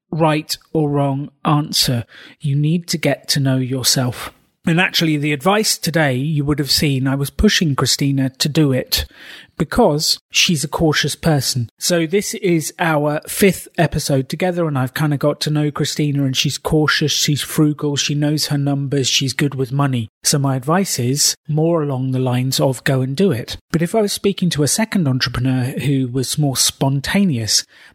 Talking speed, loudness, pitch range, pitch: 185 wpm, -17 LUFS, 135-165 Hz, 150 Hz